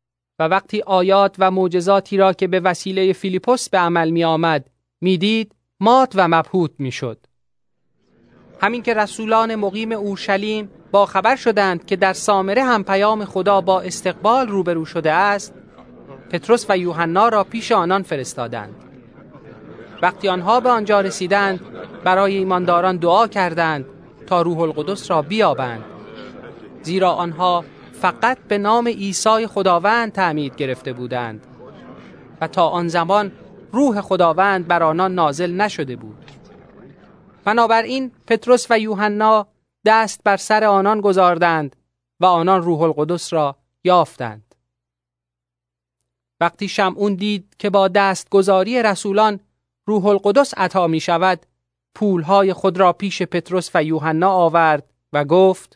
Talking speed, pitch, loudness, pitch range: 125 wpm, 185 Hz, -17 LUFS, 165-205 Hz